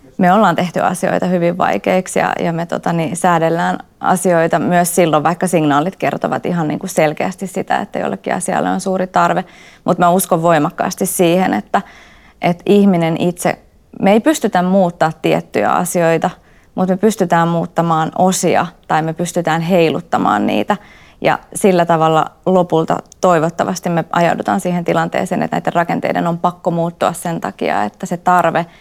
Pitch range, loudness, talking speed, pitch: 165-185 Hz, -15 LUFS, 155 wpm, 175 Hz